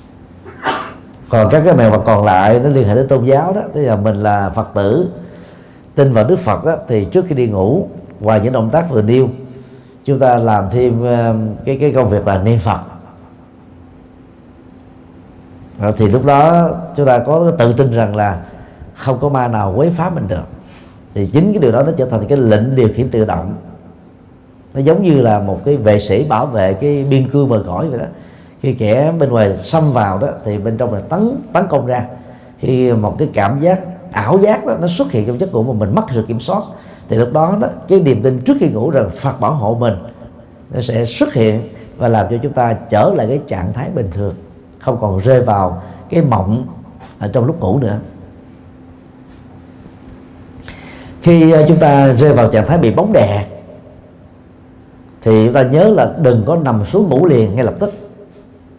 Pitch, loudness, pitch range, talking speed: 115 Hz, -13 LUFS, 100-140 Hz, 200 wpm